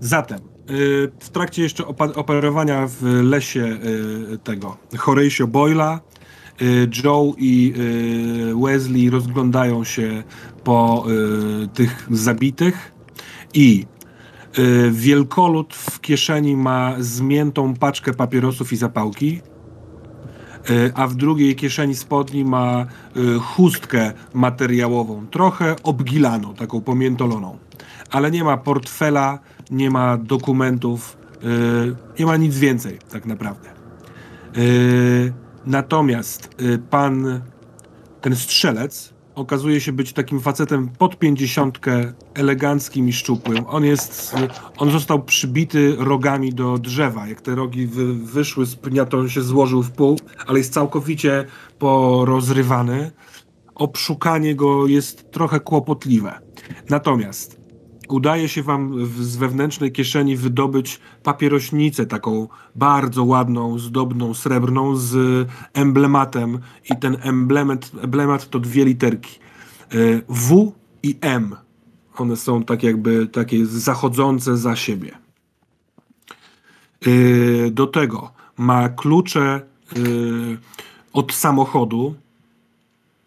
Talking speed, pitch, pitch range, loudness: 100 wpm, 130 Hz, 120-140 Hz, -18 LUFS